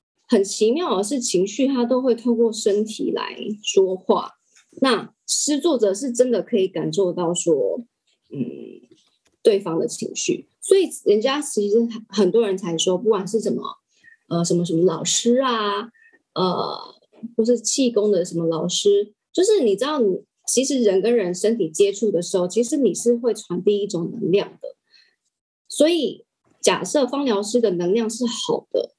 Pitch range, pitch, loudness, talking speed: 195-265 Hz, 225 Hz, -21 LUFS, 235 characters per minute